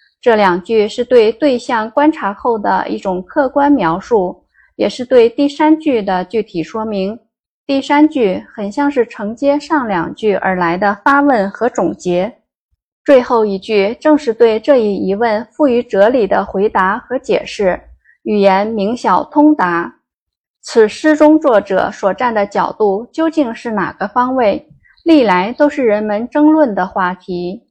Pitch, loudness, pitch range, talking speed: 225 Hz, -14 LUFS, 200-280 Hz, 220 characters per minute